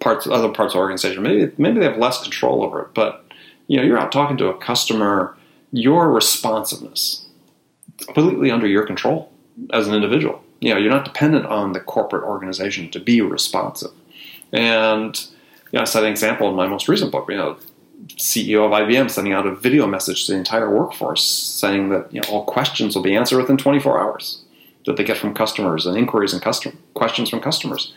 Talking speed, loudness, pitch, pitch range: 200 wpm, -18 LUFS, 110 Hz, 100-130 Hz